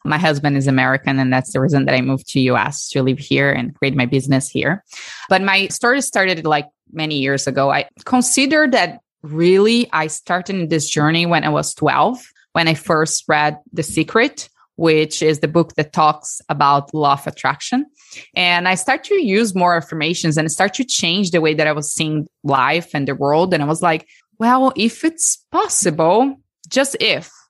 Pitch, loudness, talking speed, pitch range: 160 Hz, -16 LUFS, 195 wpm, 145-195 Hz